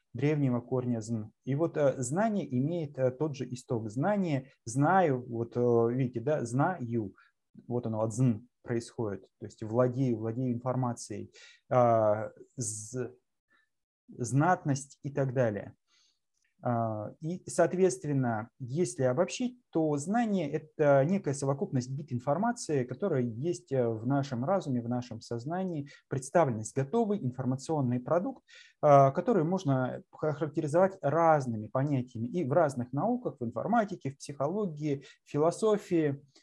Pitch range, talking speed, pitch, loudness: 120-160 Hz, 120 wpm, 135 Hz, -31 LUFS